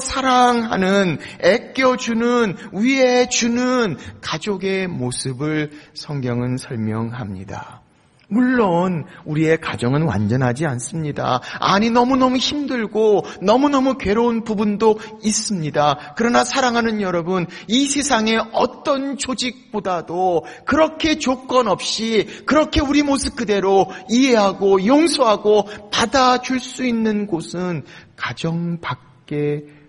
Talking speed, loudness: 245 characters per minute, -18 LUFS